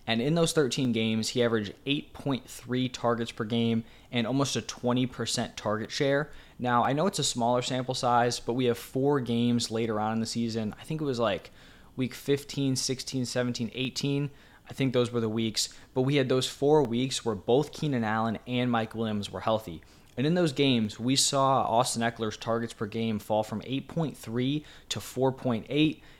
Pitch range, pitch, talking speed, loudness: 115-135 Hz, 120 Hz, 190 wpm, -29 LUFS